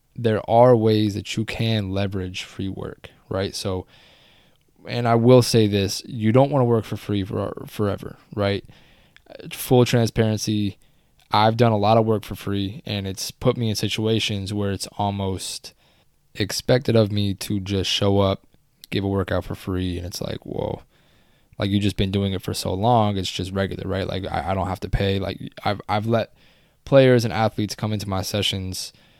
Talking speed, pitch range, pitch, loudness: 185 wpm, 95-115 Hz, 105 Hz, -22 LUFS